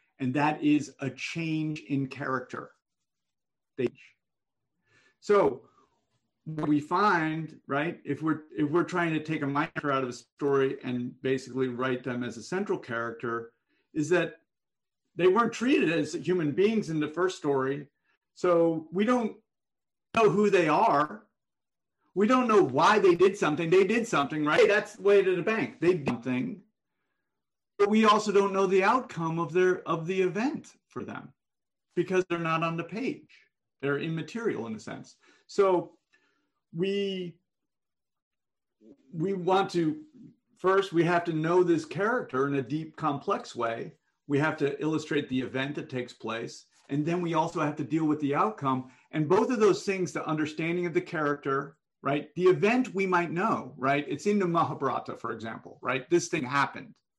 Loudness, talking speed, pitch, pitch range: -28 LUFS, 170 wpm, 165 Hz, 145-190 Hz